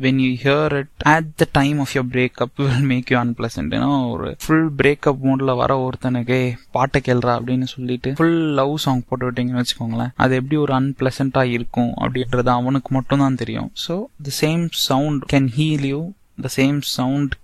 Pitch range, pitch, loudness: 125-140 Hz, 130 Hz, -19 LUFS